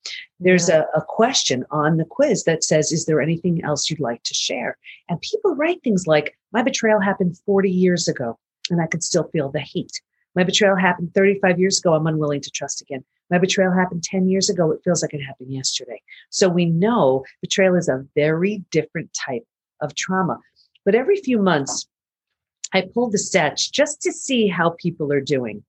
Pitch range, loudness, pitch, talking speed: 155-195 Hz, -20 LUFS, 175 Hz, 195 wpm